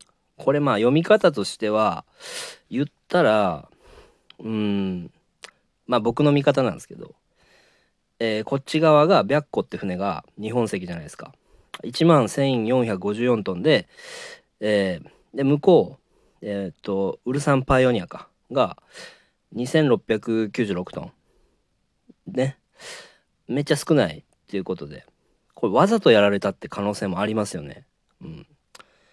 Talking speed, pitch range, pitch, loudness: 245 characters per minute, 105-140 Hz, 120 Hz, -22 LUFS